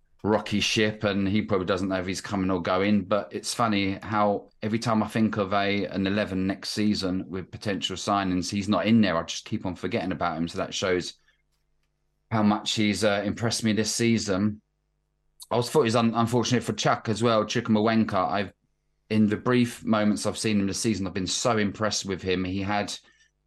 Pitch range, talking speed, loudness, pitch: 95-110 Hz, 205 wpm, -26 LUFS, 105 Hz